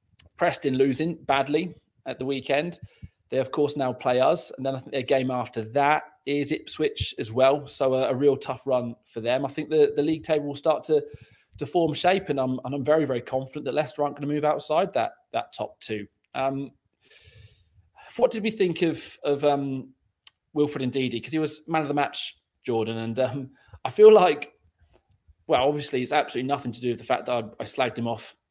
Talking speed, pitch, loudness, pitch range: 215 wpm, 135 Hz, -25 LUFS, 125-150 Hz